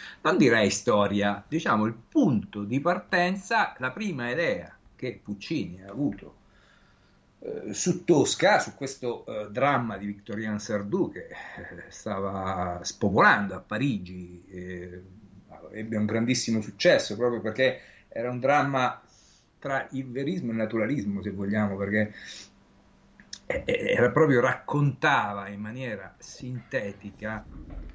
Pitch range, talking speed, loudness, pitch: 100-130 Hz, 120 wpm, -27 LUFS, 110 Hz